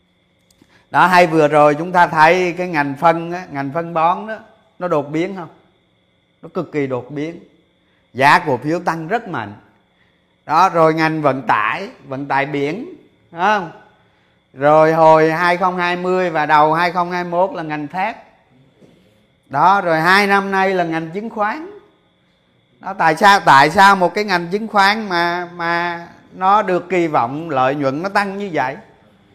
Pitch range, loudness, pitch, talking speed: 150-185 Hz, -15 LUFS, 170 Hz, 160 wpm